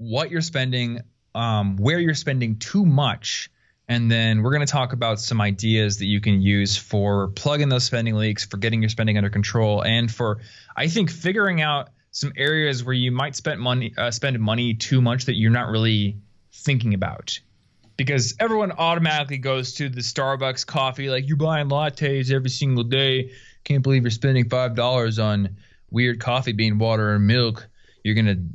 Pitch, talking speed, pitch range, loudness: 120 Hz, 185 wpm, 110-135 Hz, -22 LUFS